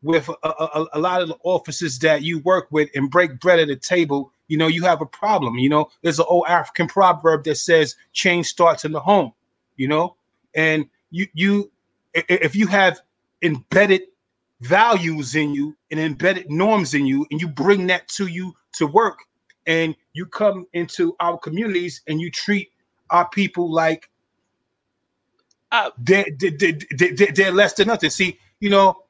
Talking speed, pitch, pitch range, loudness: 170 wpm, 170 Hz, 155-185 Hz, -19 LUFS